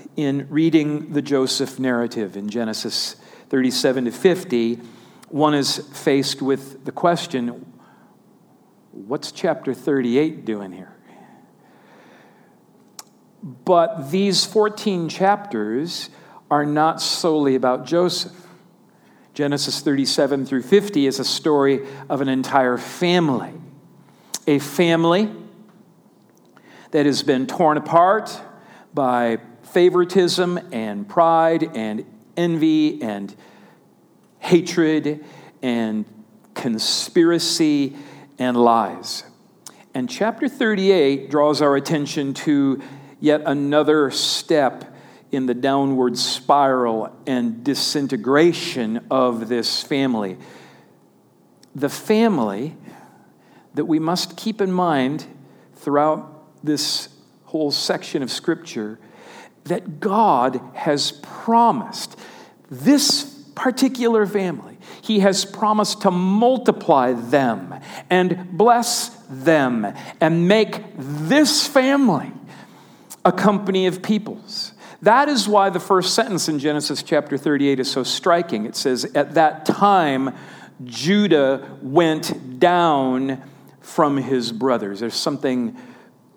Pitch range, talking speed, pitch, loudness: 130-180 Hz, 100 wpm, 150 Hz, -19 LUFS